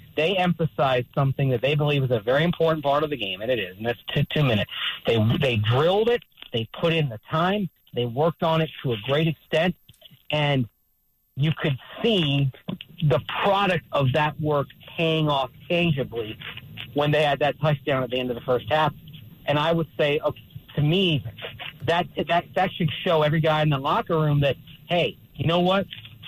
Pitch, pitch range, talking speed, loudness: 150 Hz, 130-165 Hz, 195 wpm, -24 LUFS